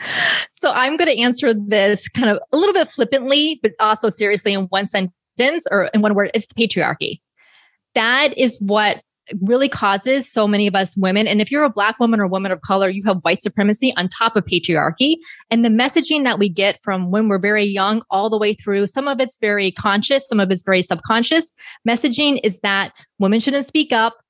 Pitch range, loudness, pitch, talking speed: 200-260 Hz, -17 LUFS, 215 Hz, 210 wpm